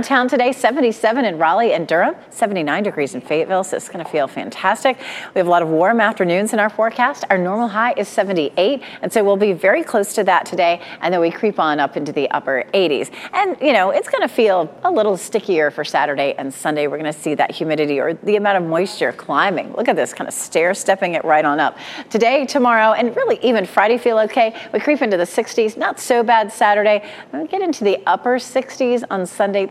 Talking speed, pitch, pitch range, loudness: 230 wpm, 215 Hz, 180-250 Hz, -17 LUFS